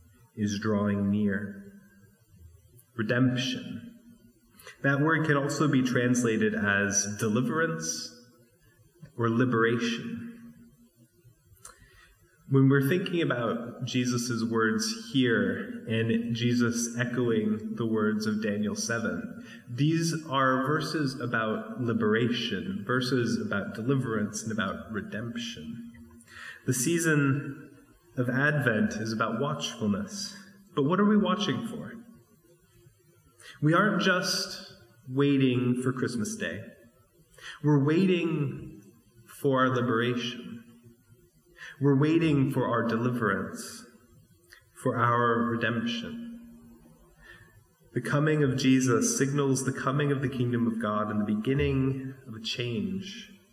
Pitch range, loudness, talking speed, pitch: 115-155 Hz, -28 LUFS, 100 wpm, 125 Hz